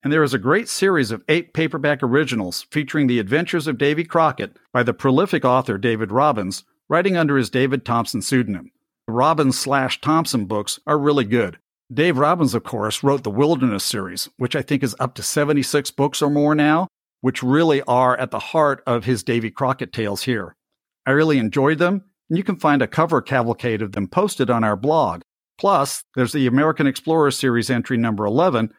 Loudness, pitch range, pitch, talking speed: -19 LUFS, 120-150 Hz, 135 Hz, 195 wpm